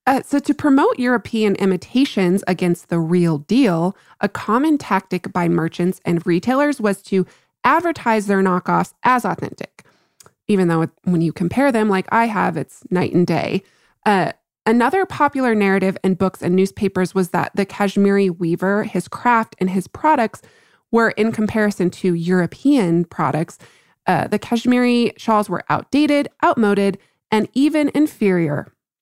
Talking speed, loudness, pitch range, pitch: 145 wpm, -18 LUFS, 180-235 Hz, 200 Hz